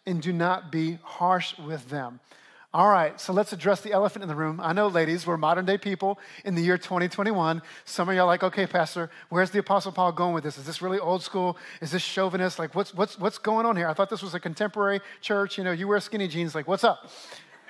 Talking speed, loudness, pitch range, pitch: 250 wpm, -26 LUFS, 170-200 Hz, 185 Hz